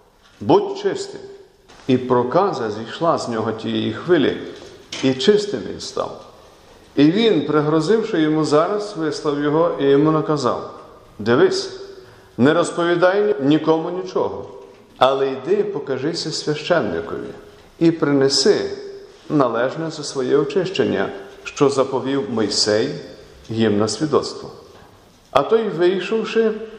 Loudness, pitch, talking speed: -19 LUFS, 165 Hz, 105 wpm